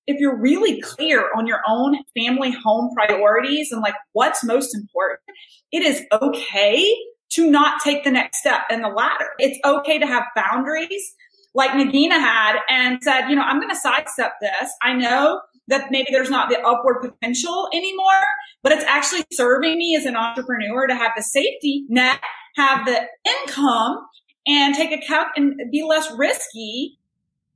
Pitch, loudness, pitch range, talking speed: 275 Hz, -18 LUFS, 240-310 Hz, 170 wpm